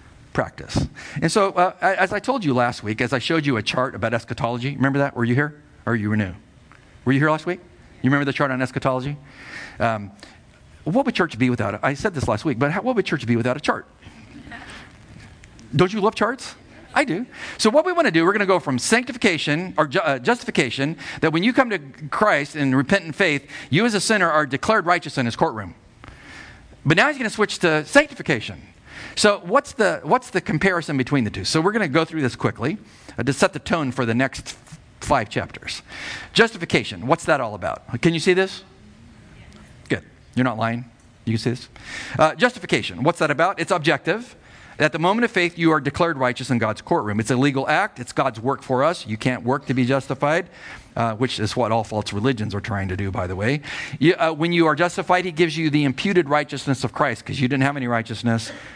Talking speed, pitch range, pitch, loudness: 225 wpm, 120-175 Hz, 145 Hz, -21 LUFS